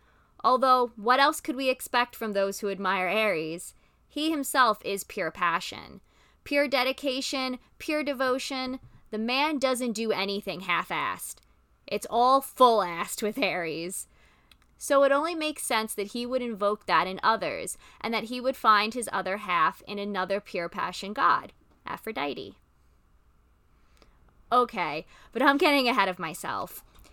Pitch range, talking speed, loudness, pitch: 195-265 Hz, 145 wpm, -27 LUFS, 230 Hz